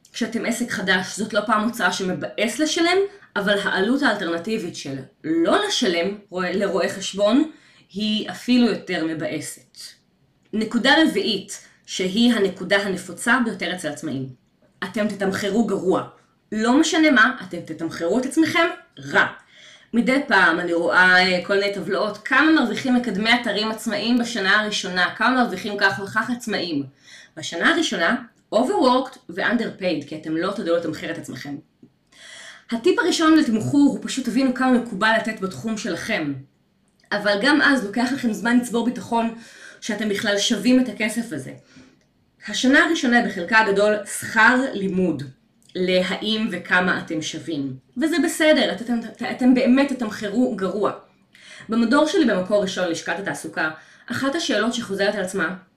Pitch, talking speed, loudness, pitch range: 215 Hz, 135 wpm, -20 LUFS, 185-245 Hz